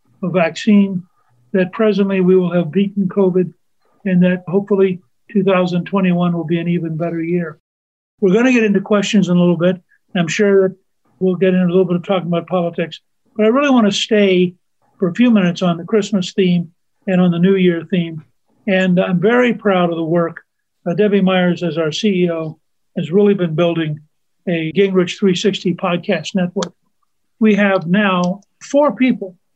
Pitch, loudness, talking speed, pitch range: 185 Hz, -16 LUFS, 180 wpm, 175-200 Hz